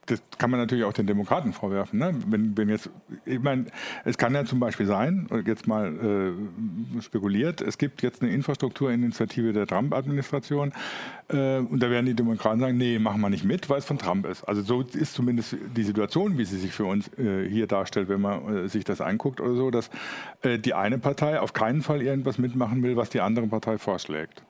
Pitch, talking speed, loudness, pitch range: 120 Hz, 210 wpm, -27 LUFS, 110-135 Hz